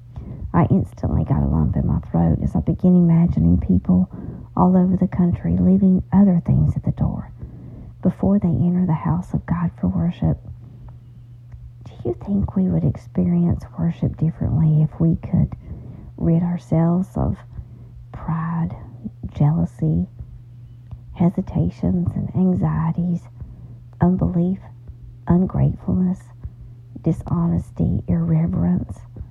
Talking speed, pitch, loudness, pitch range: 115 wpm, 135 Hz, -20 LUFS, 115-175 Hz